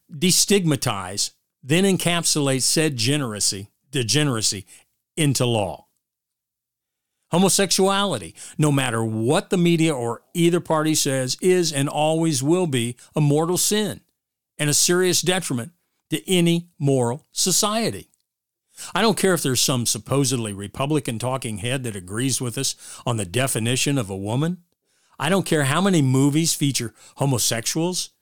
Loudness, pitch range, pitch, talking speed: -21 LUFS, 125-170 Hz, 145 Hz, 130 wpm